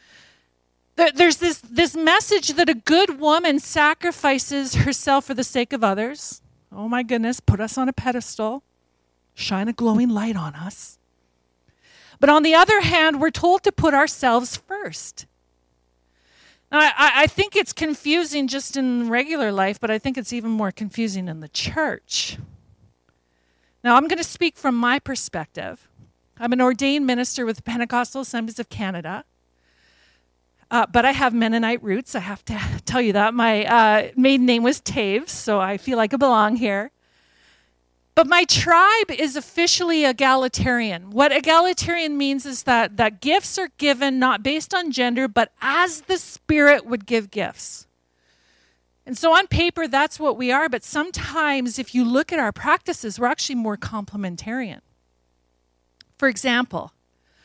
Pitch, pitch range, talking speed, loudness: 245 Hz, 200-295 Hz, 160 wpm, -20 LUFS